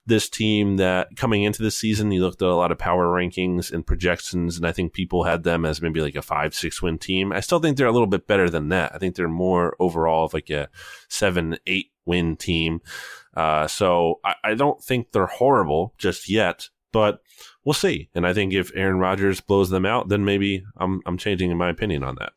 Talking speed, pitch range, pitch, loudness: 225 wpm, 85-100 Hz, 90 Hz, -22 LUFS